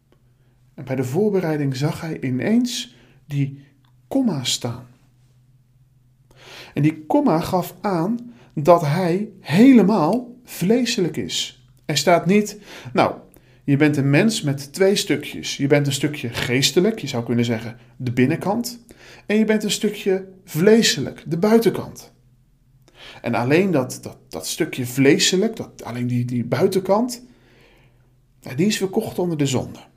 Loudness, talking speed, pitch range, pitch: -20 LUFS, 135 wpm, 125-195 Hz, 145 Hz